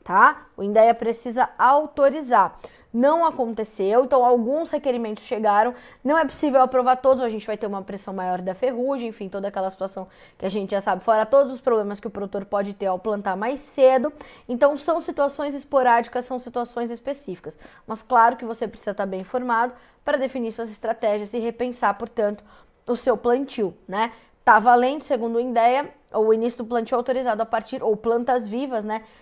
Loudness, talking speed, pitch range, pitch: -22 LUFS, 185 wpm, 215-260 Hz, 235 Hz